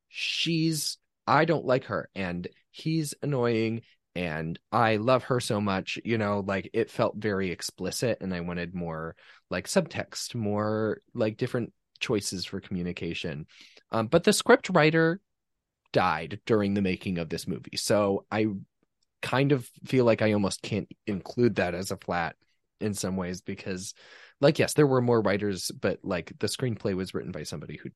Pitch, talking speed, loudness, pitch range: 105 Hz, 165 wpm, -28 LUFS, 95-125 Hz